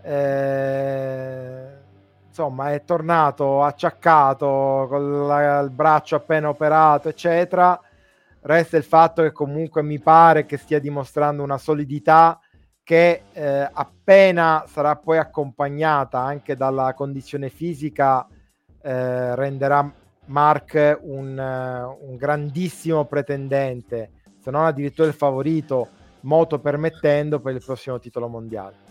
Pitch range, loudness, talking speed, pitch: 135-155 Hz, -19 LUFS, 110 wpm, 145 Hz